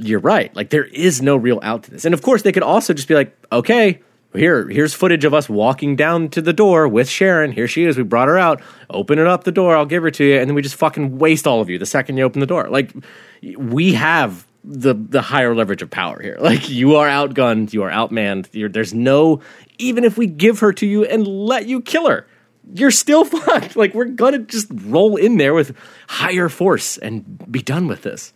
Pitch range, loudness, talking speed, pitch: 130-210 Hz, -15 LUFS, 240 wpm, 155 Hz